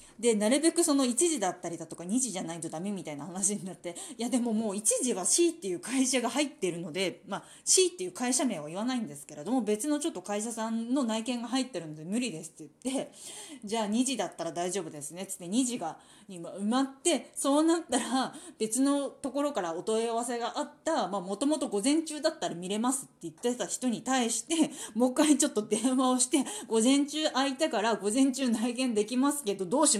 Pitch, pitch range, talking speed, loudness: 245 Hz, 200-280 Hz, 430 characters per minute, -29 LUFS